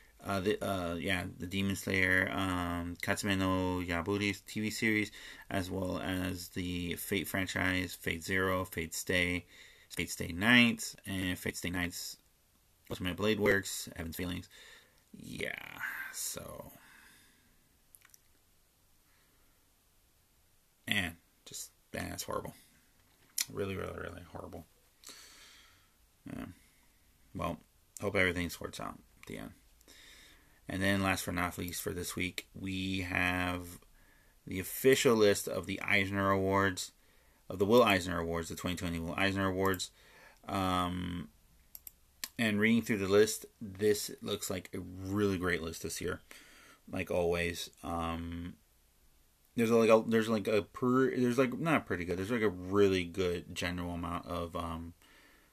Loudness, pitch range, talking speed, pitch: -33 LUFS, 85-100 Hz, 130 wpm, 90 Hz